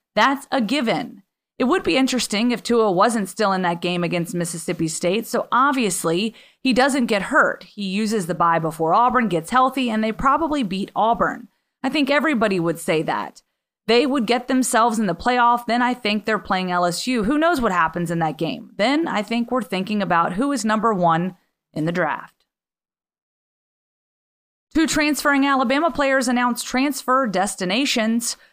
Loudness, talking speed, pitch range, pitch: -20 LUFS, 170 wpm, 190-260 Hz, 230 Hz